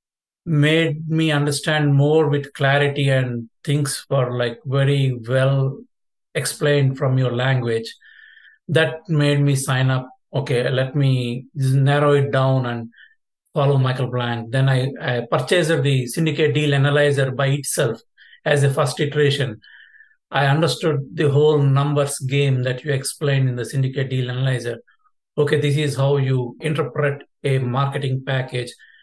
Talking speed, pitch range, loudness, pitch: 145 wpm, 130-150 Hz, -20 LUFS, 140 Hz